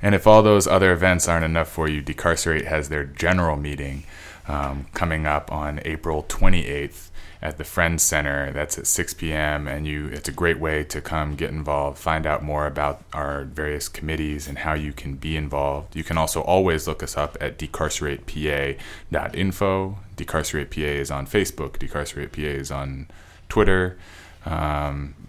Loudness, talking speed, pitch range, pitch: -23 LUFS, 170 wpm, 75-85 Hz, 75 Hz